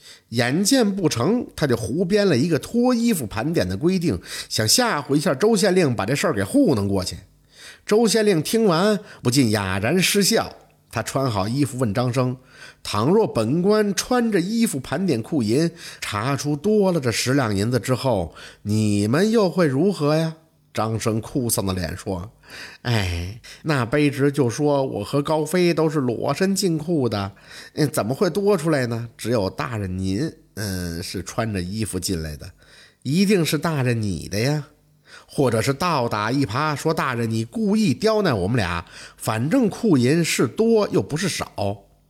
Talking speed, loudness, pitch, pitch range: 235 characters per minute, -21 LUFS, 140 Hz, 110-180 Hz